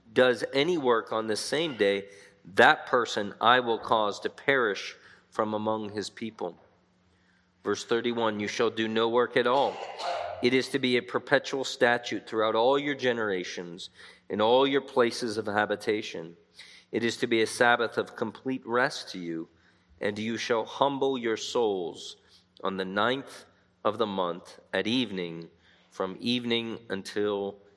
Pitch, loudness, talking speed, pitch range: 110 Hz, -28 LUFS, 155 wpm, 95-125 Hz